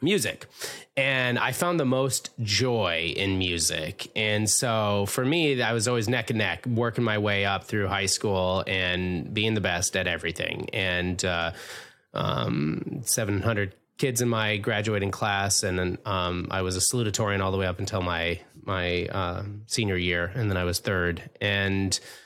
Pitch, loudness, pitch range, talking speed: 100 Hz, -26 LUFS, 90-115 Hz, 175 wpm